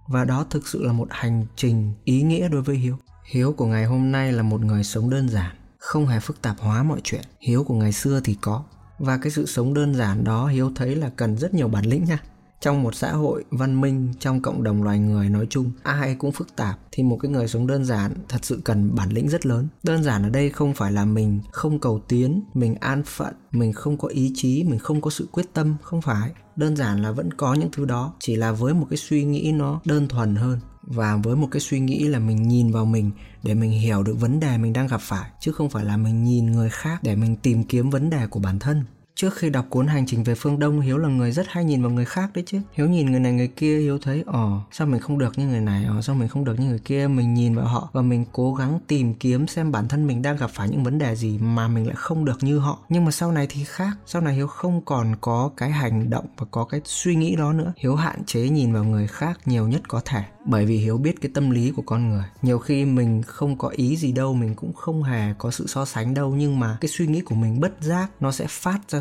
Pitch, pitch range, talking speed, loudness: 130 Hz, 115-145 Hz, 275 wpm, -23 LUFS